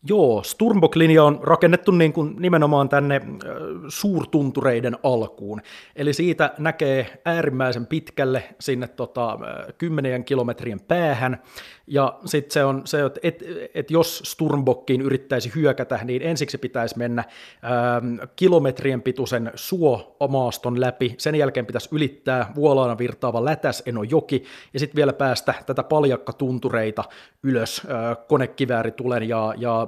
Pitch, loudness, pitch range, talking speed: 135 Hz, -22 LUFS, 125-150 Hz, 125 wpm